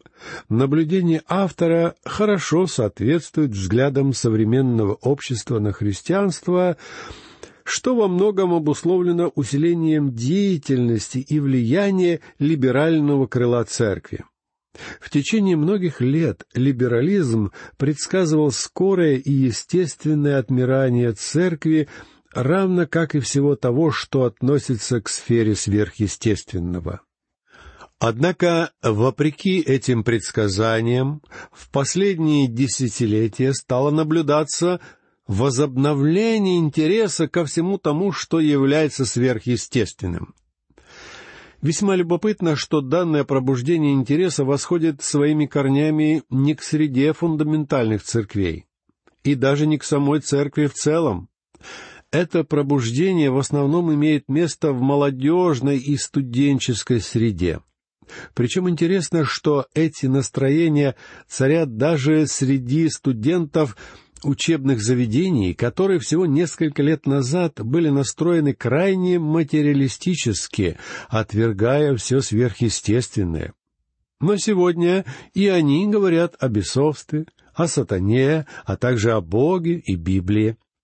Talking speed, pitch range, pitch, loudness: 95 wpm, 125-165 Hz, 145 Hz, -20 LUFS